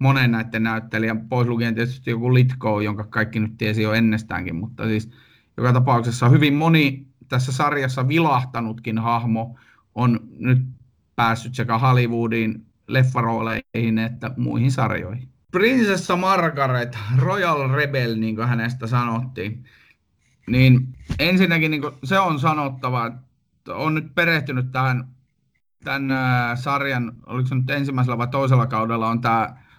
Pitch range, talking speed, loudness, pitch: 115-135 Hz, 130 wpm, -21 LUFS, 125 Hz